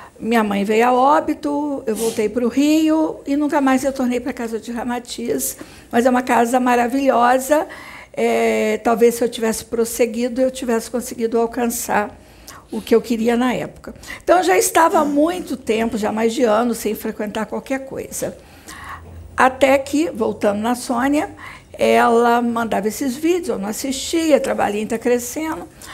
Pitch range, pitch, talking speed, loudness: 230-275 Hz, 245 Hz, 160 wpm, -18 LUFS